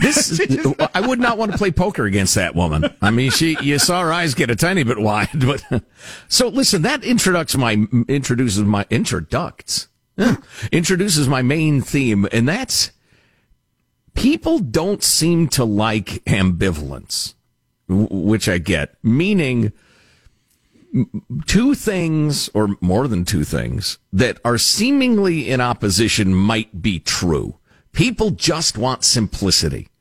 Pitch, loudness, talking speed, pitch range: 125 Hz, -17 LUFS, 135 wpm, 105-170 Hz